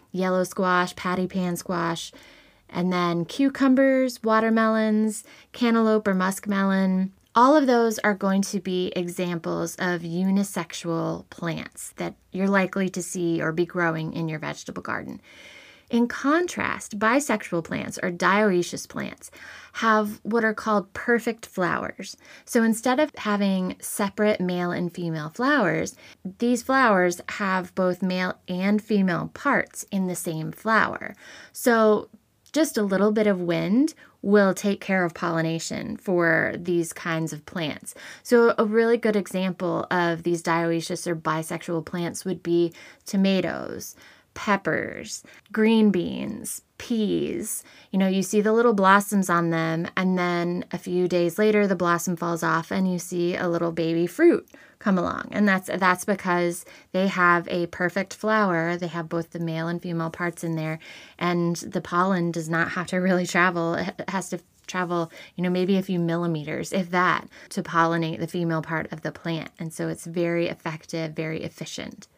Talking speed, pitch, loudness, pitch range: 155 wpm, 185 Hz, -24 LUFS, 170-210 Hz